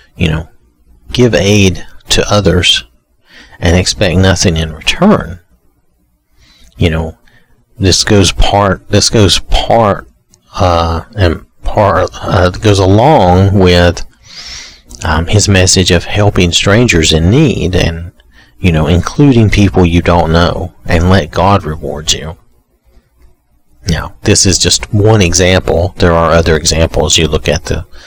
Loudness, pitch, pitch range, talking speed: -9 LUFS, 85 Hz, 80-95 Hz, 130 wpm